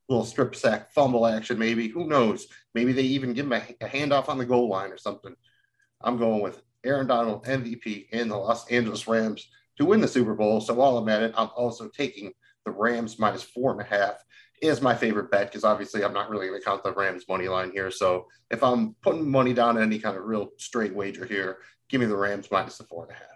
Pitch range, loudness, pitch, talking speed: 100-125 Hz, -26 LUFS, 115 Hz, 240 wpm